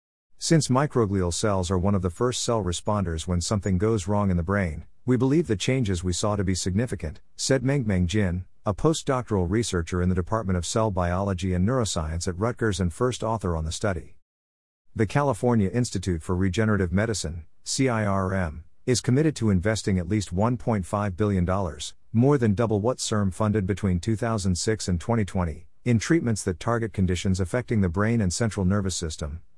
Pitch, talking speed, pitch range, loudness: 100 Hz, 170 wpm, 90-115 Hz, -25 LUFS